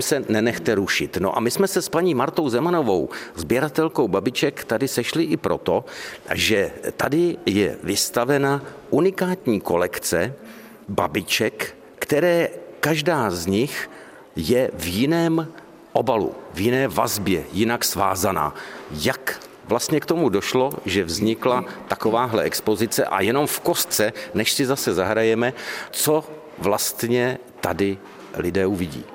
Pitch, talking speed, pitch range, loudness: 130 Hz, 125 wpm, 110-165 Hz, -22 LUFS